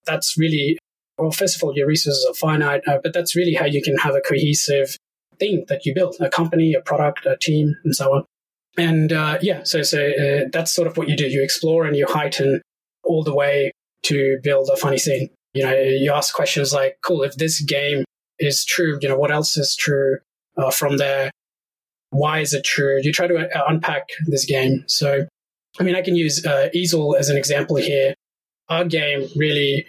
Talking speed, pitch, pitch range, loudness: 210 wpm, 150 Hz, 140-170 Hz, -19 LUFS